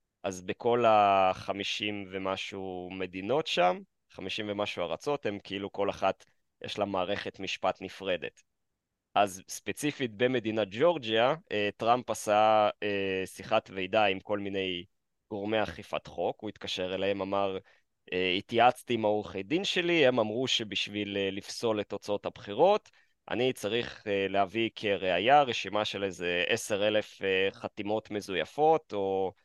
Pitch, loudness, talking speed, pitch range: 100 Hz, -30 LUFS, 120 wpm, 95-110 Hz